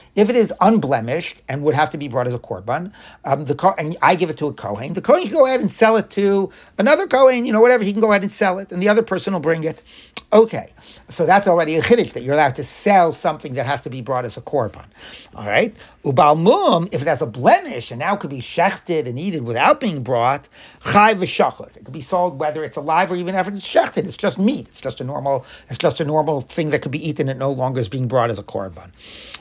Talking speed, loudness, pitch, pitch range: 265 wpm, -18 LUFS, 160 Hz, 140-200 Hz